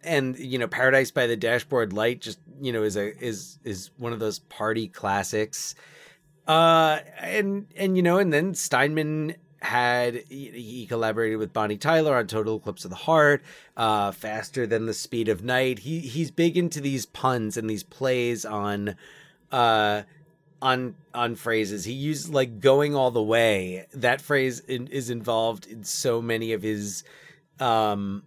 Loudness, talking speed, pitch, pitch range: -25 LUFS, 170 wpm, 120 Hz, 110-145 Hz